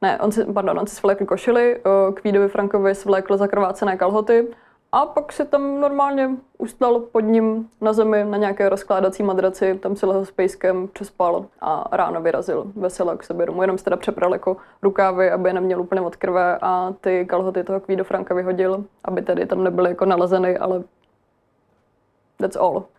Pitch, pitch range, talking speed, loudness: 195 Hz, 185-215 Hz, 175 wpm, -20 LUFS